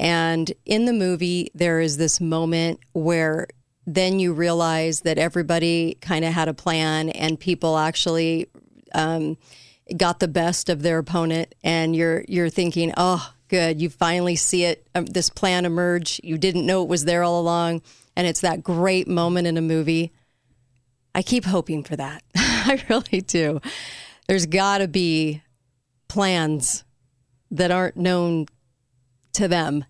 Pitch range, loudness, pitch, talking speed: 160-180 Hz, -22 LUFS, 170 Hz, 155 wpm